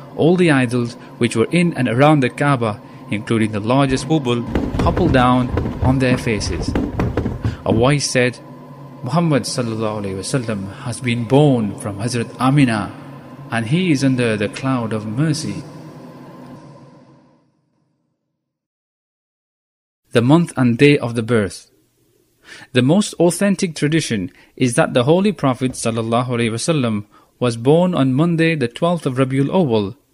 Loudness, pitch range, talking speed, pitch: -17 LUFS, 115-145 Hz, 130 wpm, 130 Hz